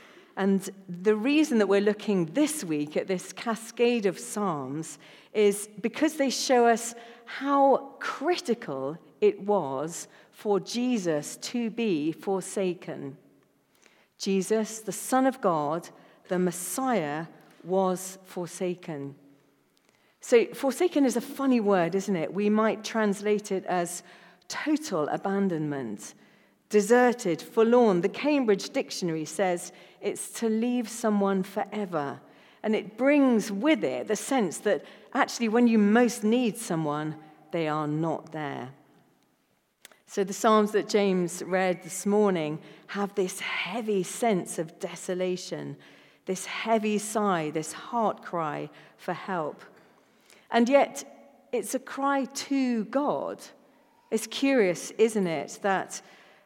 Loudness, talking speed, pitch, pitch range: -27 LUFS, 120 wpm, 200 Hz, 175-235 Hz